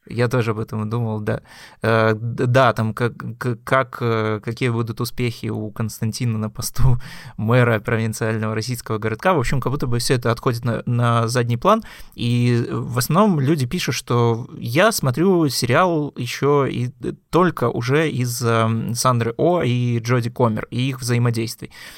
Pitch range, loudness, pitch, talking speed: 115-135 Hz, -20 LUFS, 120 Hz, 150 wpm